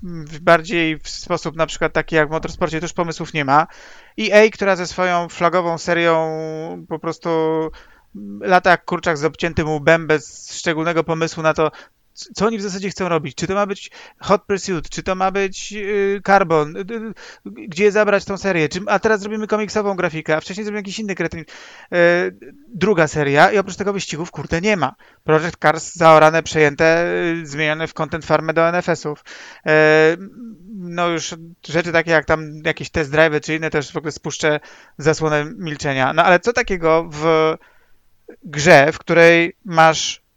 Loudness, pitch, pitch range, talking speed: -17 LUFS, 165 Hz, 155-190 Hz, 170 wpm